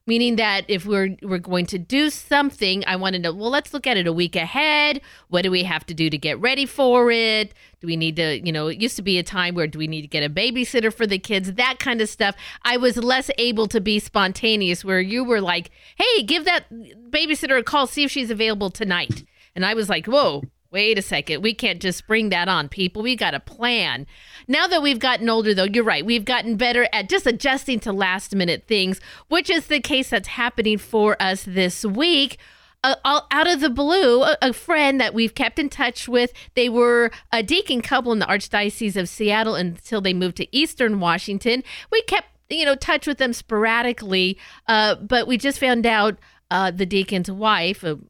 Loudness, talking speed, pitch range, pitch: -20 LUFS, 220 wpm, 190-260 Hz, 225 Hz